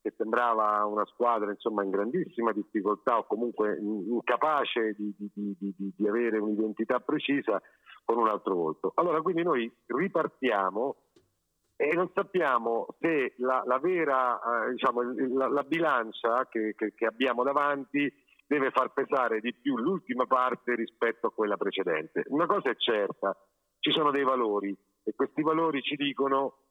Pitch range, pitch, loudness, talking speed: 105-140 Hz, 120 Hz, -29 LUFS, 150 wpm